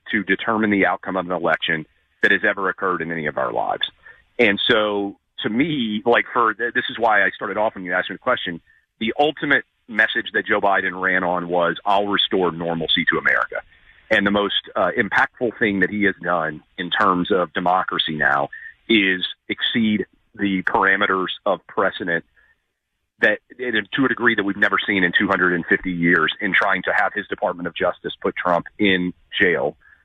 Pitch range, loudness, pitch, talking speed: 90-105 Hz, -20 LUFS, 95 Hz, 185 wpm